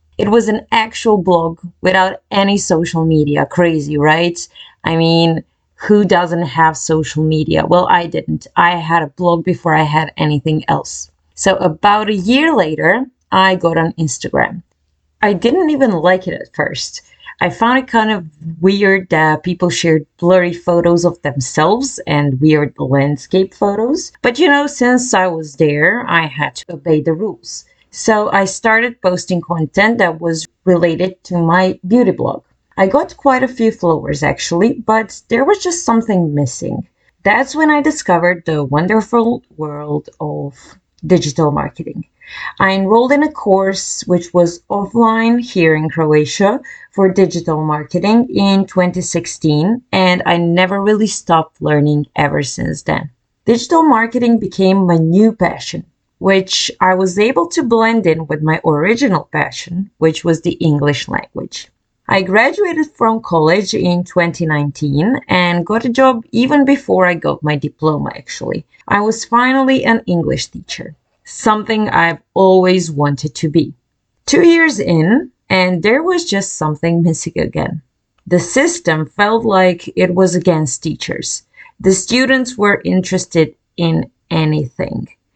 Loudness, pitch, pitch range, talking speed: -14 LUFS, 180 Hz, 160-215 Hz, 150 wpm